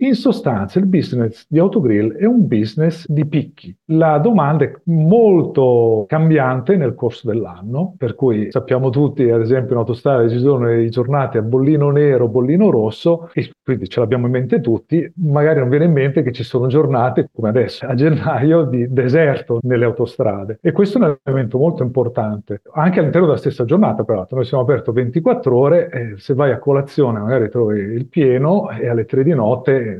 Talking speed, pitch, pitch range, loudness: 180 wpm, 135 Hz, 120-160 Hz, -16 LUFS